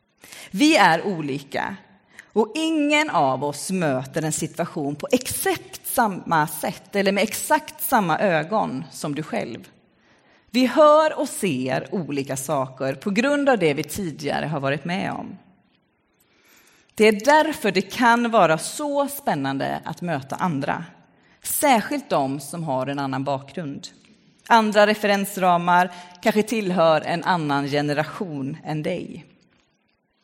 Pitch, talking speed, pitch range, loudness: 180 Hz, 130 wpm, 145-230 Hz, -22 LUFS